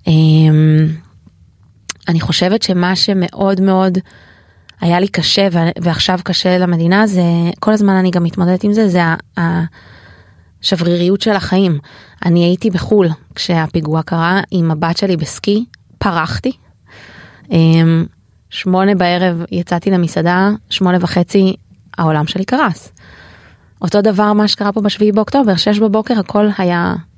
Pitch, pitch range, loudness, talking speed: 175 Hz, 160-195 Hz, -13 LUFS, 120 wpm